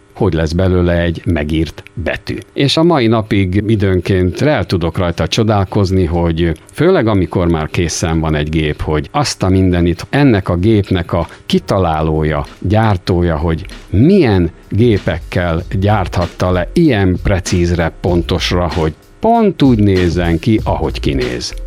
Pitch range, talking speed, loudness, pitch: 85-100 Hz, 135 wpm, -14 LUFS, 90 Hz